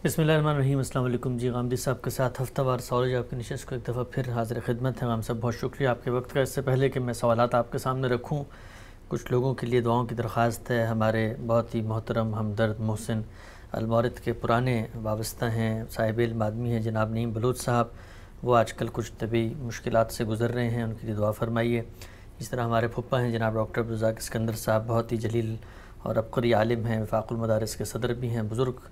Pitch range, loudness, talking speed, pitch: 110-125 Hz, -28 LUFS, 220 wpm, 115 Hz